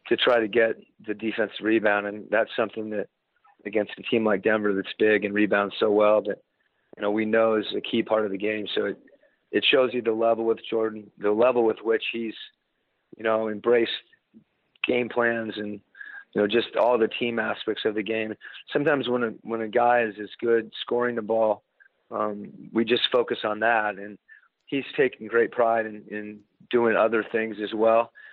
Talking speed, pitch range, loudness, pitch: 200 wpm, 105-115 Hz, -25 LUFS, 110 Hz